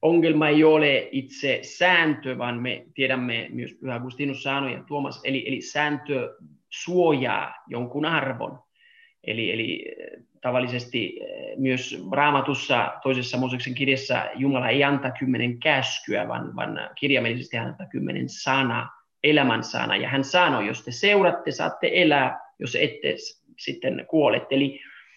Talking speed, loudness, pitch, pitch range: 125 wpm, -24 LUFS, 135 Hz, 125-155 Hz